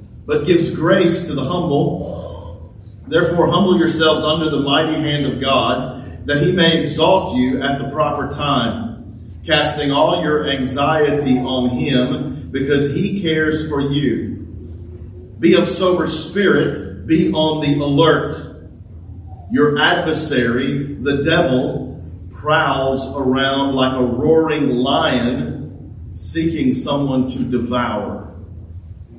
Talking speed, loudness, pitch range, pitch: 115 wpm, -17 LUFS, 120-155 Hz, 140 Hz